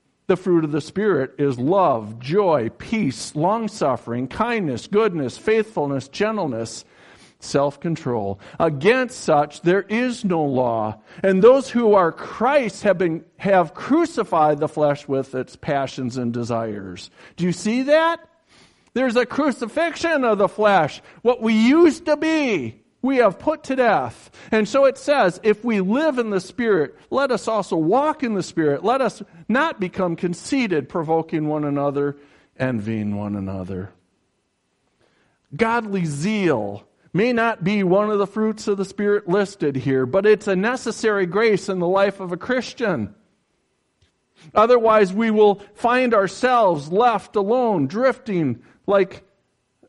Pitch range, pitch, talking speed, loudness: 150-230 Hz, 195 Hz, 145 wpm, -20 LUFS